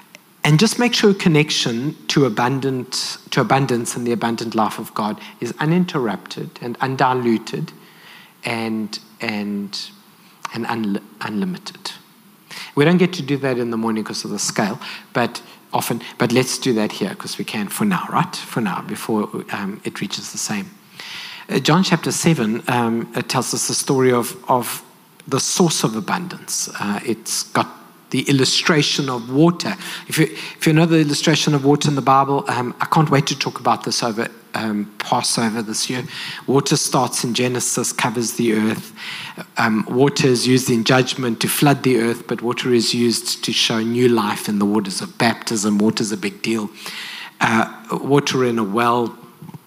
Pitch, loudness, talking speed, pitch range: 130 Hz, -19 LUFS, 175 wpm, 115-160 Hz